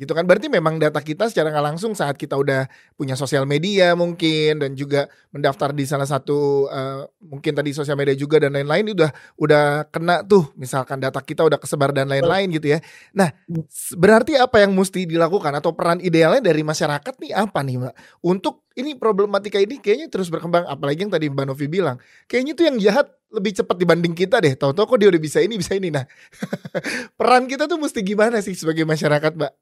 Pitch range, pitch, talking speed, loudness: 145-200 Hz, 160 Hz, 200 wpm, -19 LUFS